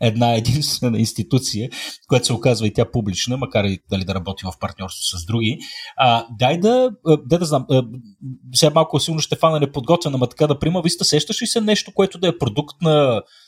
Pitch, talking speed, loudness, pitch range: 130 Hz, 200 wpm, -19 LUFS, 115-160 Hz